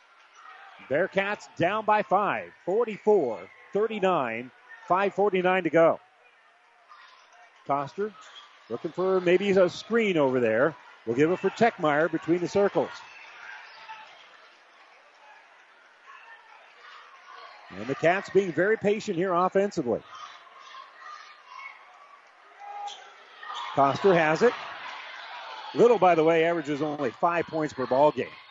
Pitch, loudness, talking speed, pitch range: 190 Hz, -25 LUFS, 100 wpm, 165-215 Hz